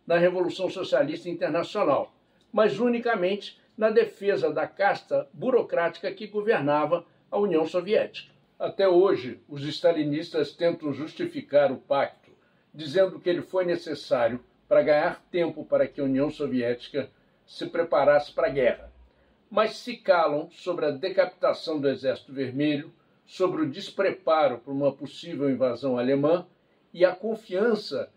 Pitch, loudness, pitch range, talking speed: 175 Hz, -26 LUFS, 150-210 Hz, 130 wpm